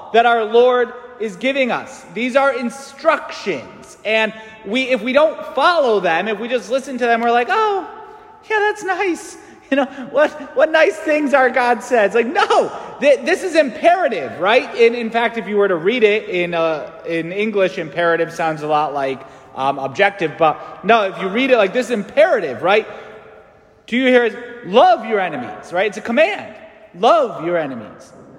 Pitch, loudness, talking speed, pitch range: 240 Hz, -17 LUFS, 180 wpm, 205-295 Hz